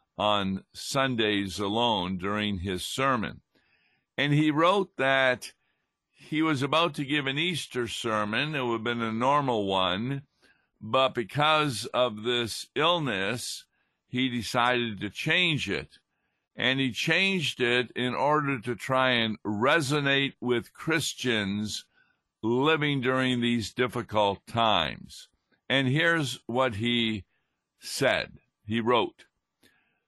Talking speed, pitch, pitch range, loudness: 120 wpm, 125 Hz, 110-140 Hz, -27 LUFS